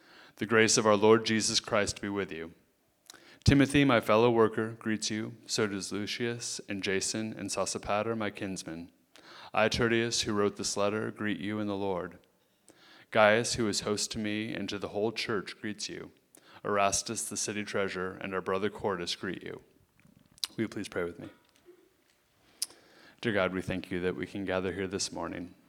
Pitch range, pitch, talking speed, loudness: 100-110 Hz, 105 Hz, 180 wpm, -30 LUFS